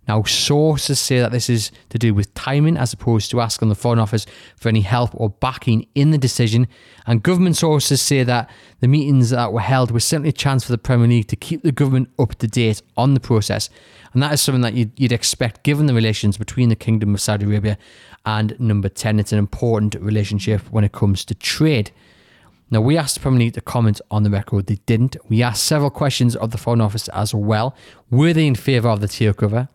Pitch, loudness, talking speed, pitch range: 115 Hz, -18 LUFS, 230 wpm, 105-130 Hz